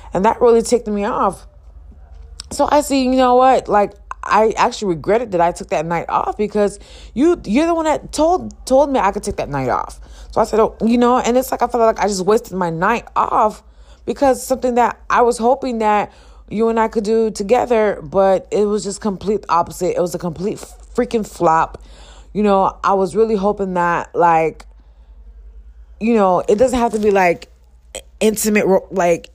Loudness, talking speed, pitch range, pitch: -16 LUFS, 200 wpm, 175-235 Hz, 210 Hz